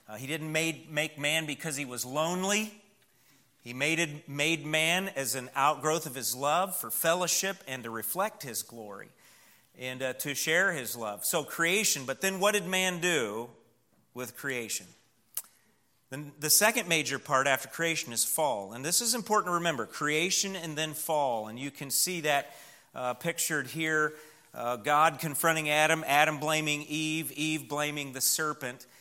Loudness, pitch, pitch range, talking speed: -29 LUFS, 150 Hz, 130-165 Hz, 165 wpm